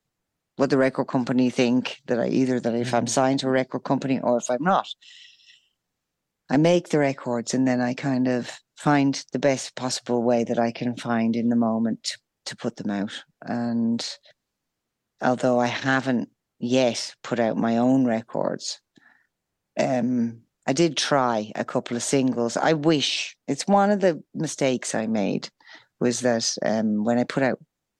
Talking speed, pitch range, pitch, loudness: 170 wpm, 120-135 Hz, 125 Hz, -24 LUFS